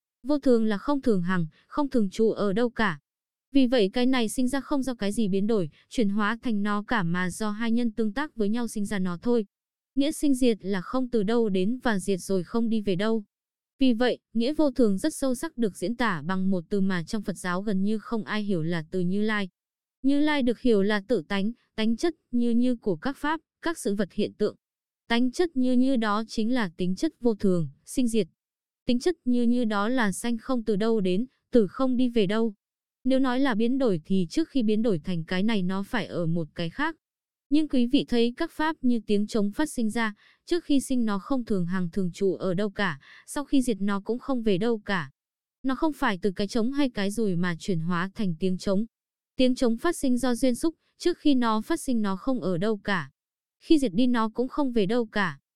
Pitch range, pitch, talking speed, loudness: 200-255 Hz, 225 Hz, 240 wpm, -27 LUFS